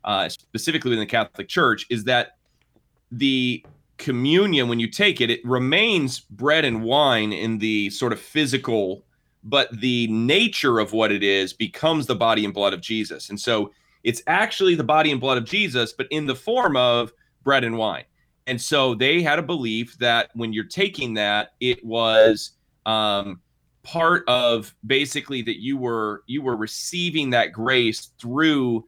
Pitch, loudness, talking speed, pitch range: 120 Hz, -21 LUFS, 170 wpm, 110-135 Hz